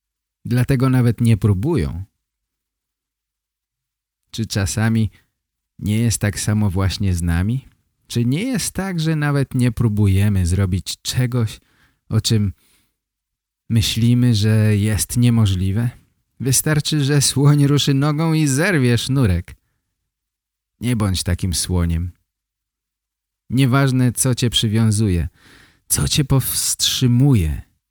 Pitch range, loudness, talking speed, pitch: 95-130 Hz, -18 LUFS, 105 wpm, 110 Hz